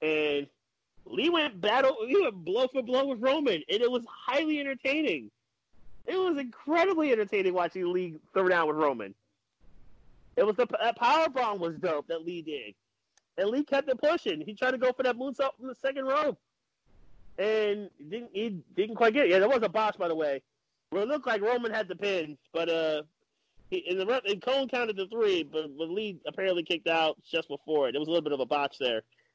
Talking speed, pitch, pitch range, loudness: 215 wpm, 210 Hz, 165-270 Hz, -29 LUFS